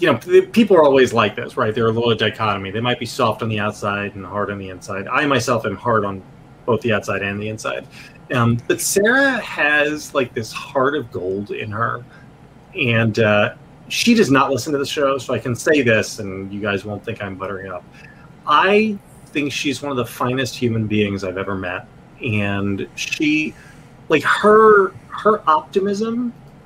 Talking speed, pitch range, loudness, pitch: 195 wpm, 105-150 Hz, -18 LUFS, 120 Hz